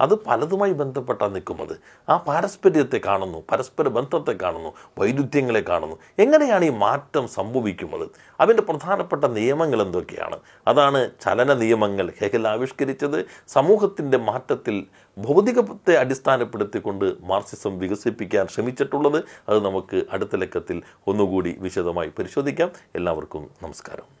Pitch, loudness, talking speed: 140 Hz, -22 LUFS, 100 wpm